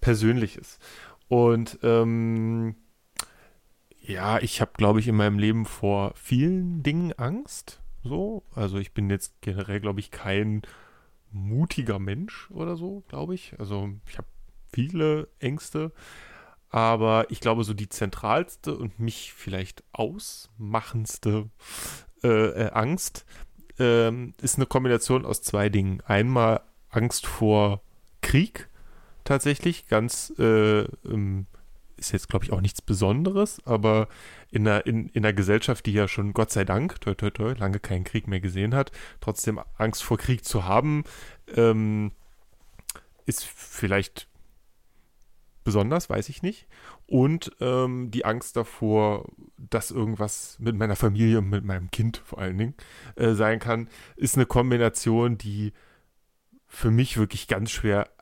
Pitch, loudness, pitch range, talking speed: 110 Hz, -26 LUFS, 105-120 Hz, 135 wpm